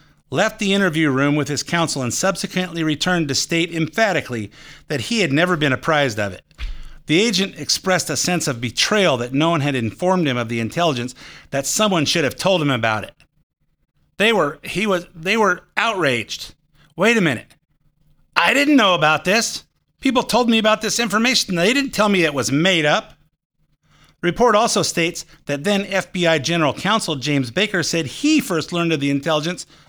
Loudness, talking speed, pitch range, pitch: -18 LUFS, 185 wpm, 145-195 Hz, 165 Hz